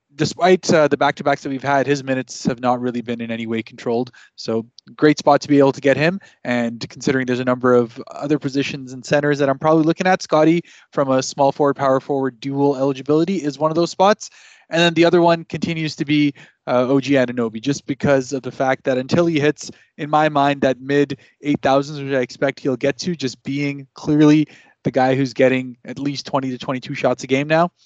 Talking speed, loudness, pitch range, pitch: 225 wpm, -19 LUFS, 130-150 Hz, 140 Hz